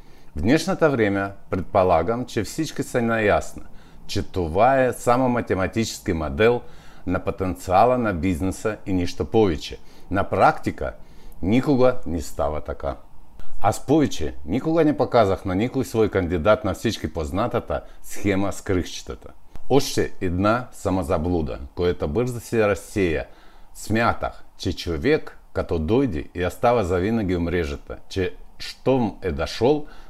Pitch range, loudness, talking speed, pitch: 90-120 Hz, -23 LUFS, 115 wpm, 100 Hz